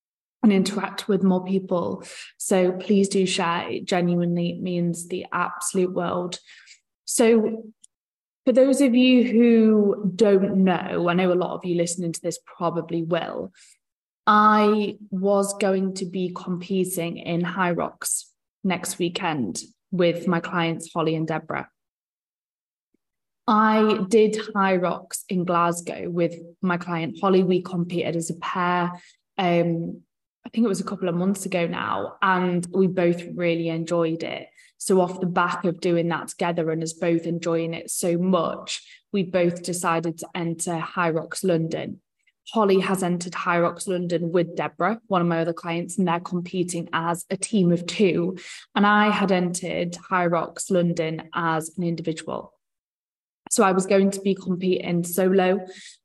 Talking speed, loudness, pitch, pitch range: 155 wpm, -23 LUFS, 180 Hz, 170-195 Hz